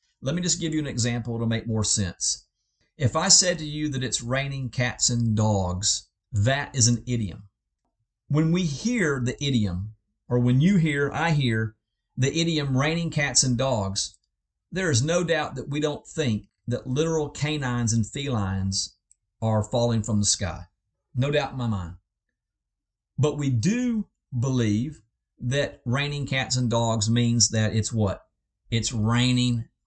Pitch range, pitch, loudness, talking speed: 110-145 Hz, 120 Hz, -24 LUFS, 165 wpm